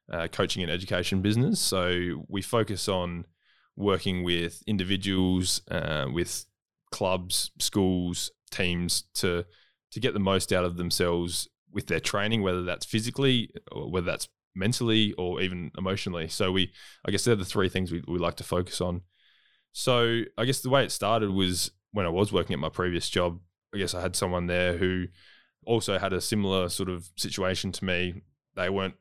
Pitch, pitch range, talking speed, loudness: 95 Hz, 90-100 Hz, 180 wpm, -28 LUFS